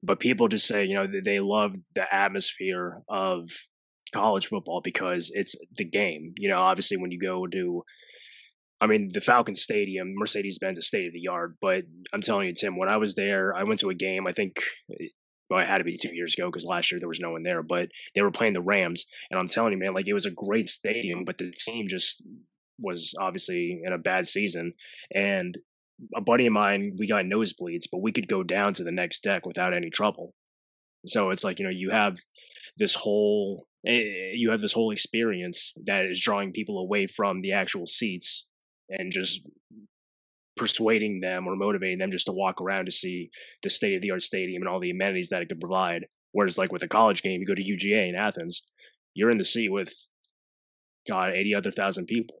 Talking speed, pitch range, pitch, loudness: 215 wpm, 90-115 Hz, 100 Hz, -26 LUFS